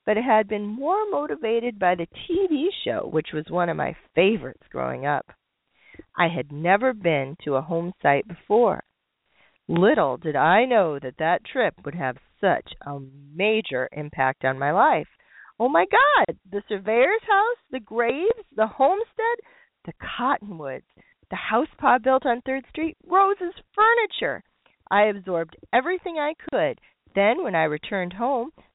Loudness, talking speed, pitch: -23 LUFS, 155 wpm, 220 Hz